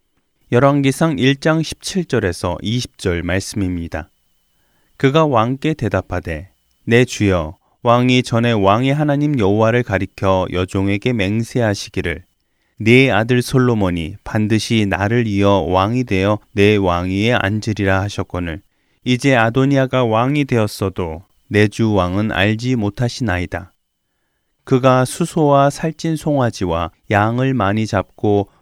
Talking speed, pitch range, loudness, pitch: 260 characters per minute, 95-125 Hz, -16 LUFS, 110 Hz